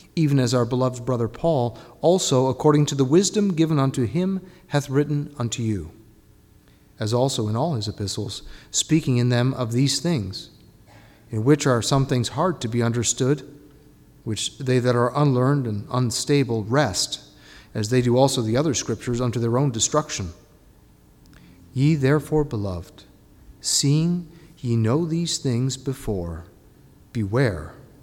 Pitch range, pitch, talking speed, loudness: 110-145 Hz, 125 Hz, 145 wpm, -22 LUFS